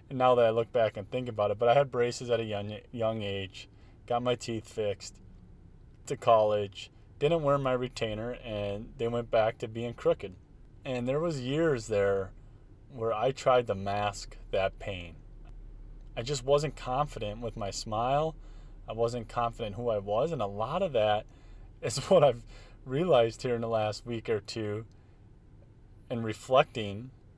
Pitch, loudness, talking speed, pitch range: 115 Hz, -30 LUFS, 175 wpm, 105-125 Hz